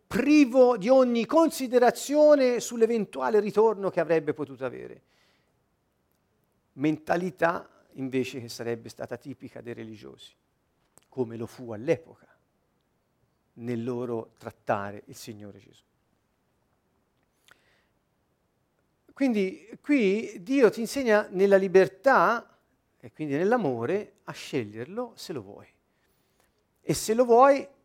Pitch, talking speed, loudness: 190 Hz, 100 wpm, -25 LUFS